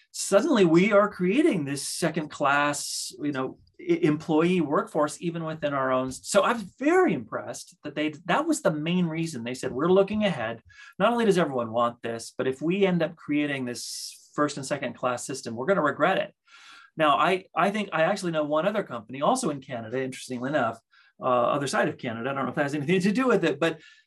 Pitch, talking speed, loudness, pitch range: 160 Hz, 220 wpm, -26 LUFS, 135-195 Hz